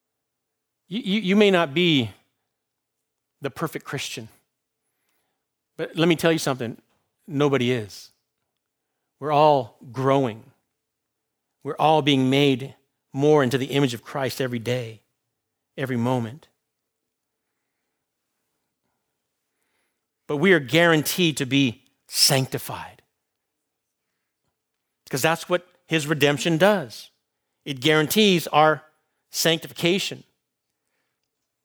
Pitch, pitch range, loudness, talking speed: 140 Hz, 130-165 Hz, -22 LUFS, 95 wpm